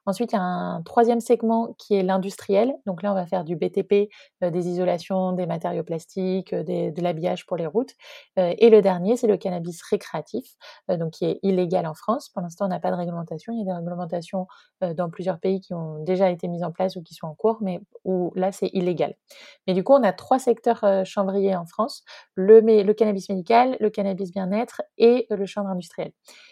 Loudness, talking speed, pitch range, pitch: -23 LUFS, 225 wpm, 180-215 Hz, 190 Hz